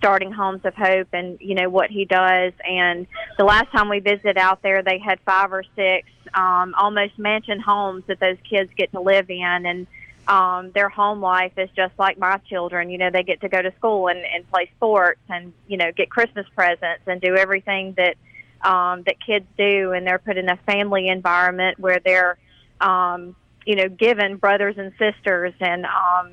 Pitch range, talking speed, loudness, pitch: 180-200 Hz, 200 wpm, -19 LUFS, 190 Hz